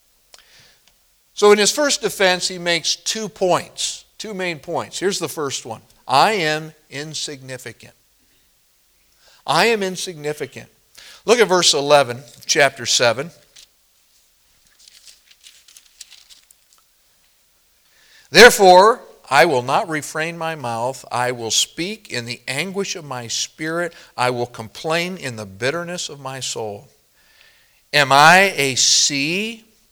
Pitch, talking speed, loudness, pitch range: 155 Hz, 115 wpm, -17 LUFS, 130-185 Hz